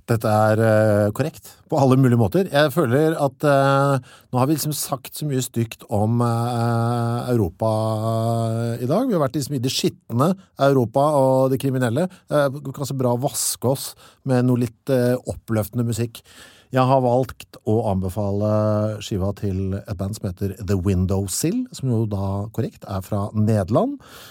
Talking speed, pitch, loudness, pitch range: 170 wpm, 120 Hz, -21 LUFS, 105-135 Hz